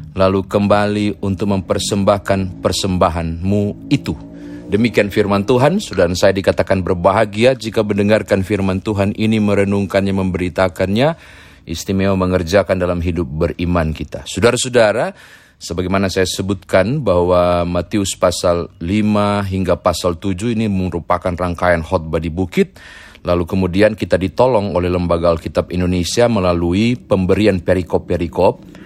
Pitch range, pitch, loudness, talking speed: 90-105 Hz, 95 Hz, -16 LUFS, 110 wpm